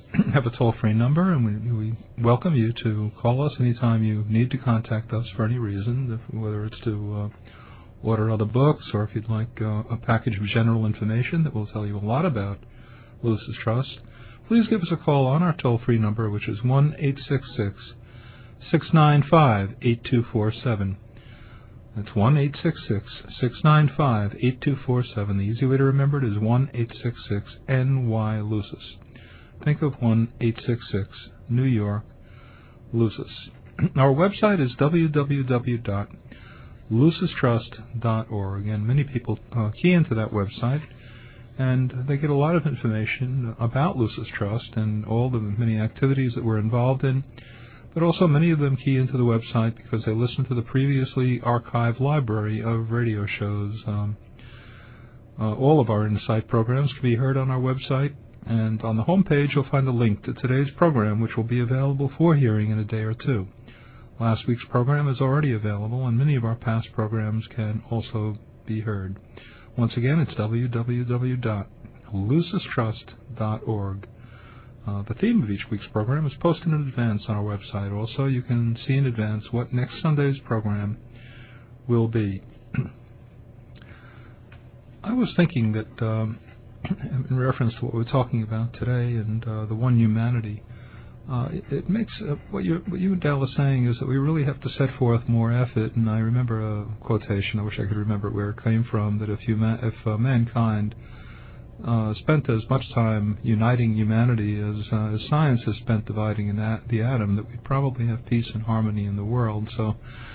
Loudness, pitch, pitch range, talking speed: -24 LUFS, 115 Hz, 110-130 Hz, 165 wpm